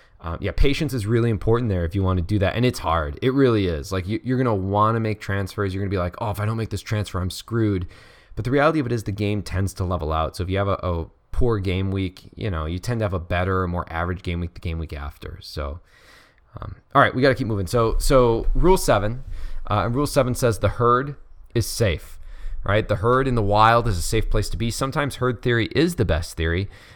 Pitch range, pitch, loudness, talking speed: 90-115 Hz, 105 Hz, -22 LUFS, 270 wpm